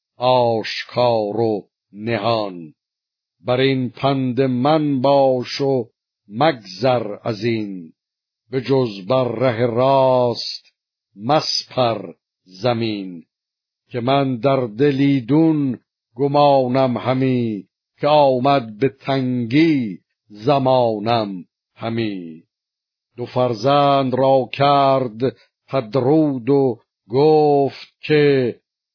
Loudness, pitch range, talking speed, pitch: -18 LUFS, 115-135 Hz, 80 wpm, 130 Hz